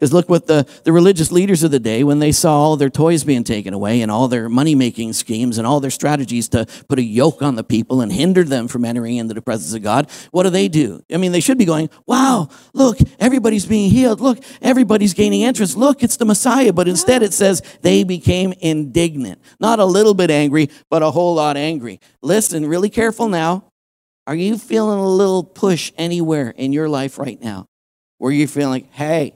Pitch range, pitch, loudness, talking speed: 130-195 Hz, 160 Hz, -15 LUFS, 215 wpm